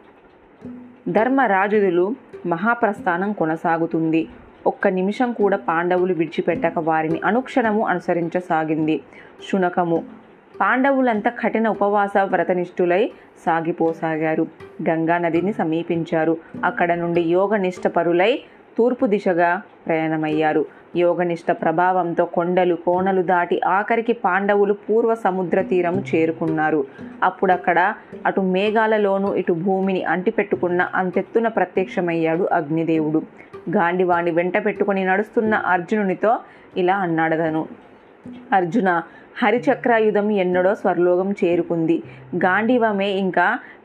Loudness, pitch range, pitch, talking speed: -20 LUFS, 170-210 Hz, 185 Hz, 80 wpm